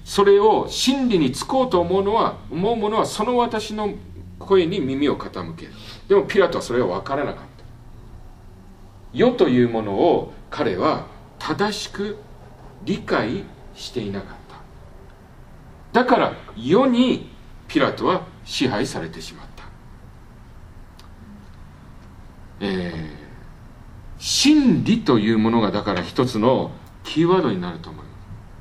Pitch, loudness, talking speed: 115 Hz, -20 LUFS, 230 characters per minute